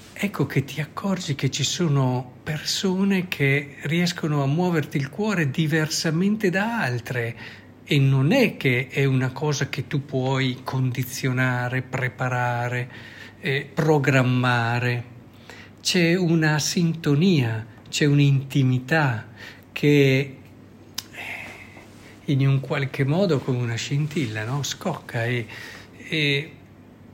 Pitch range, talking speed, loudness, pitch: 120-155 Hz, 110 wpm, -23 LUFS, 135 Hz